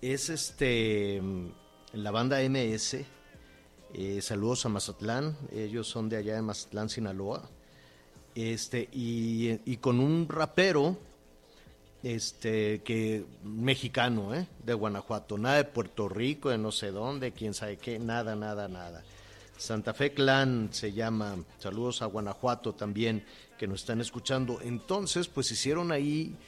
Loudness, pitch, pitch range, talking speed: -32 LUFS, 115 Hz, 105-125 Hz, 135 wpm